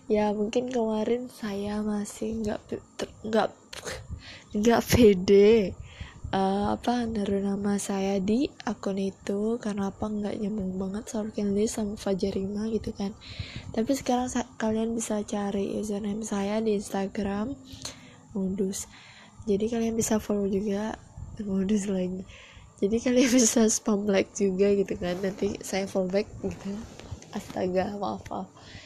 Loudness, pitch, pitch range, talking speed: -28 LUFS, 210 Hz, 200-225 Hz, 135 wpm